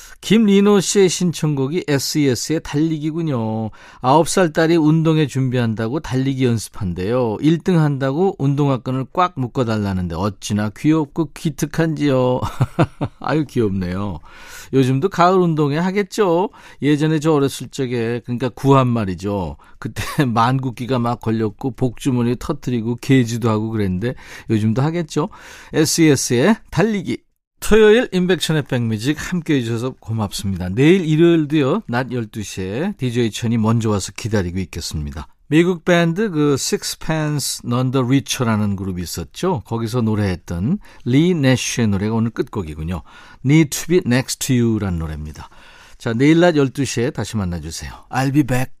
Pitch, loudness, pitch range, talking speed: 130 Hz, -18 LUFS, 110-155 Hz, 355 characters per minute